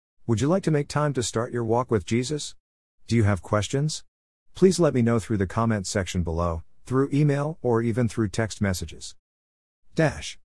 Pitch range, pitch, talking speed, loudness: 85-130 Hz, 115 Hz, 190 wpm, -25 LUFS